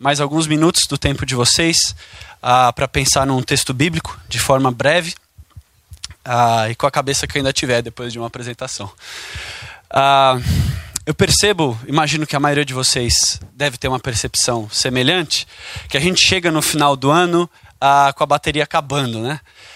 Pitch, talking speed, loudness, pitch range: 140 Hz, 175 wpm, -16 LUFS, 125-150 Hz